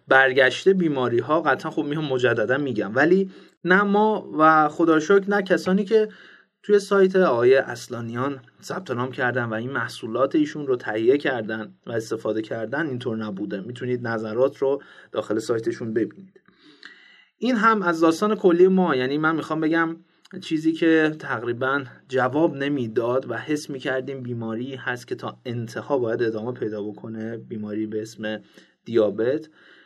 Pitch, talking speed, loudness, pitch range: 140 Hz, 145 wpm, -23 LUFS, 120-180 Hz